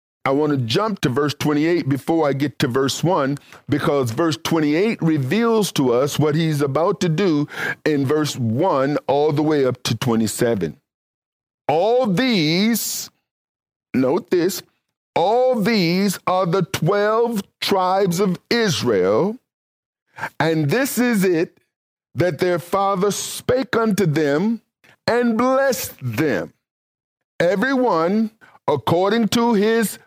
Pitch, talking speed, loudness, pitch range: 180 Hz, 125 wpm, -19 LUFS, 150-220 Hz